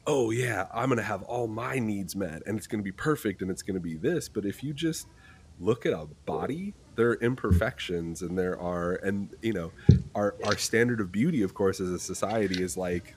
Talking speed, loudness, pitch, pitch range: 220 wpm, -29 LUFS, 100 Hz, 95-115 Hz